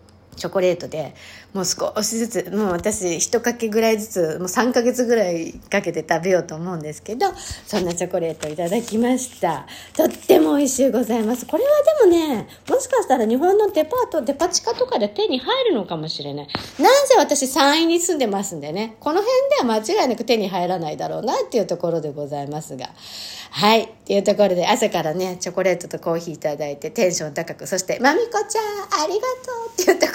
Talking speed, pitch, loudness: 430 characters per minute, 220 Hz, -20 LUFS